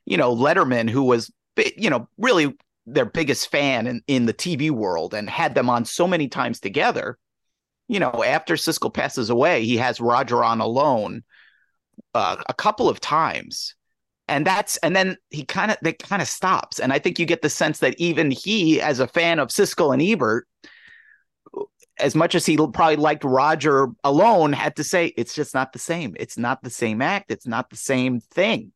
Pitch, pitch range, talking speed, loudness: 150 Hz, 130-170 Hz, 195 wpm, -21 LUFS